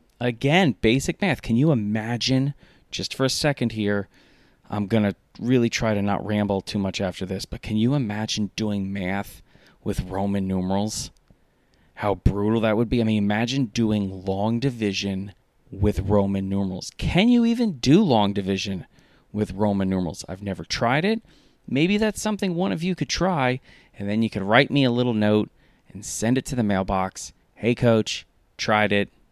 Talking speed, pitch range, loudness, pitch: 175 wpm, 100-130 Hz, -23 LUFS, 110 Hz